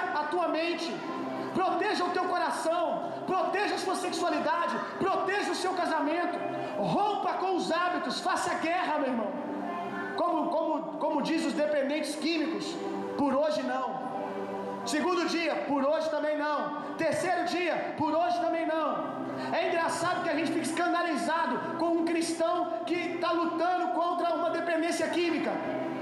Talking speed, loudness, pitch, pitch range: 145 wpm, -30 LUFS, 335 Hz, 310-345 Hz